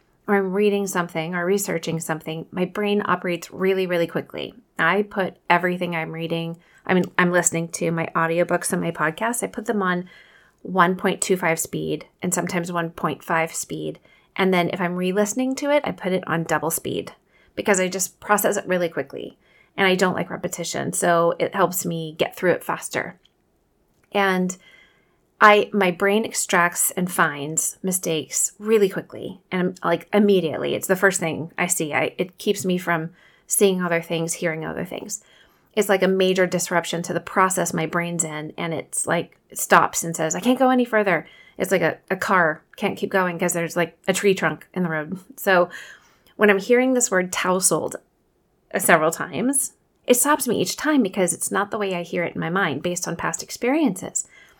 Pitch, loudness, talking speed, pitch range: 180 Hz, -22 LUFS, 185 wpm, 170-195 Hz